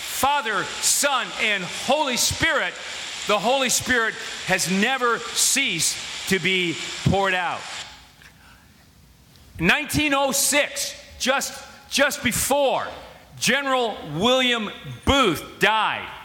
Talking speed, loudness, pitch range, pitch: 85 wpm, -21 LUFS, 195-275 Hz, 245 Hz